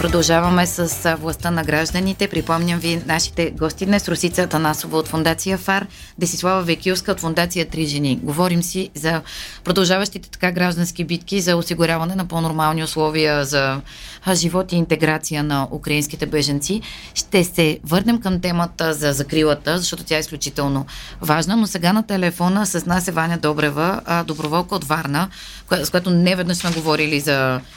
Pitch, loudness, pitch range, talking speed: 170 Hz, -19 LUFS, 155-180 Hz, 150 wpm